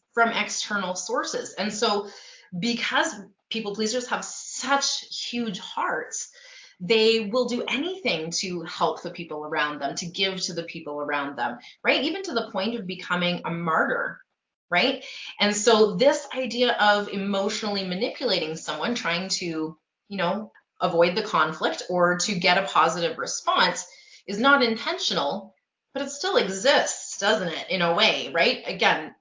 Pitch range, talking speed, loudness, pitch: 175-245 Hz, 150 wpm, -24 LUFS, 205 Hz